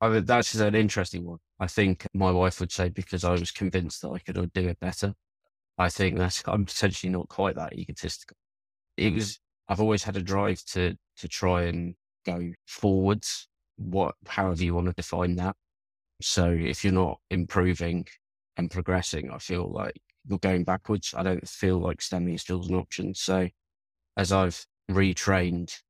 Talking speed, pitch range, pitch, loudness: 180 wpm, 85-95 Hz, 90 Hz, -28 LUFS